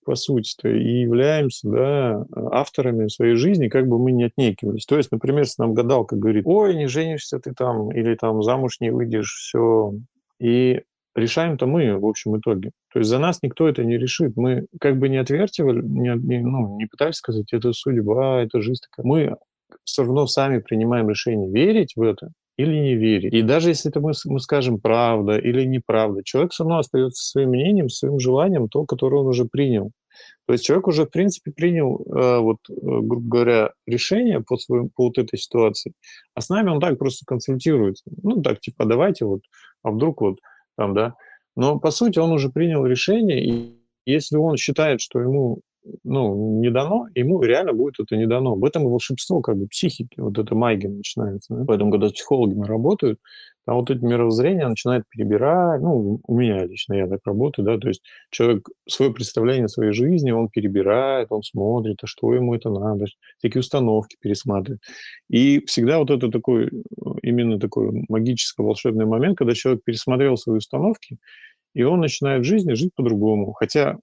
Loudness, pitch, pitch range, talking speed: -20 LUFS, 125 Hz, 110-145 Hz, 185 wpm